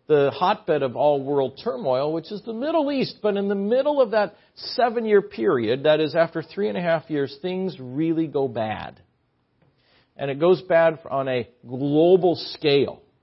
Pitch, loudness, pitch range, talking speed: 165 Hz, -22 LUFS, 140-205 Hz, 180 wpm